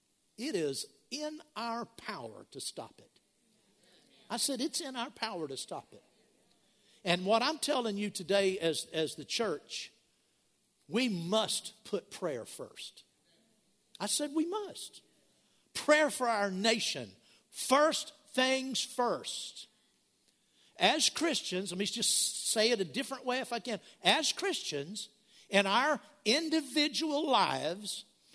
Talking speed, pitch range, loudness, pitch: 130 wpm, 205-295 Hz, -32 LUFS, 235 Hz